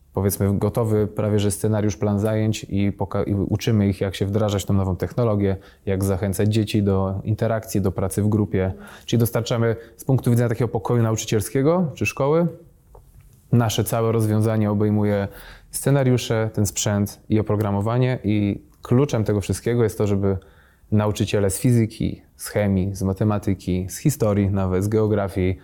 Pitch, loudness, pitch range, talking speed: 105 Hz, -22 LUFS, 100-115 Hz, 155 wpm